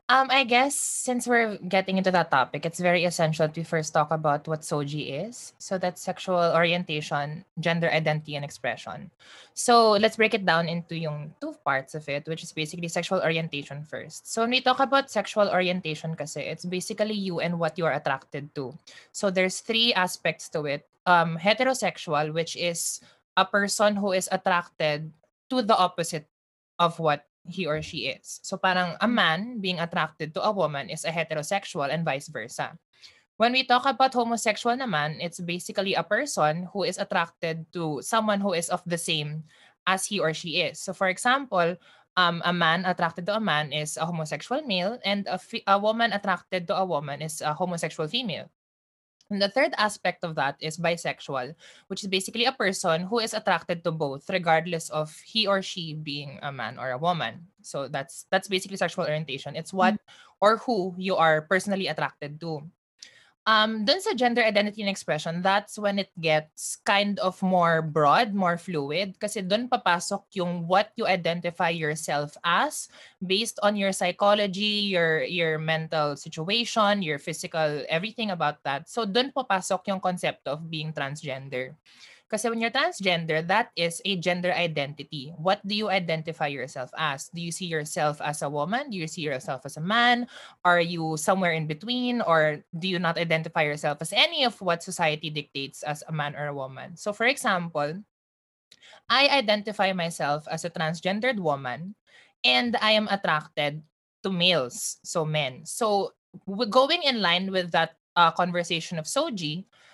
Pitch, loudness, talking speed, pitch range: 175 Hz, -26 LUFS, 175 wpm, 155-200 Hz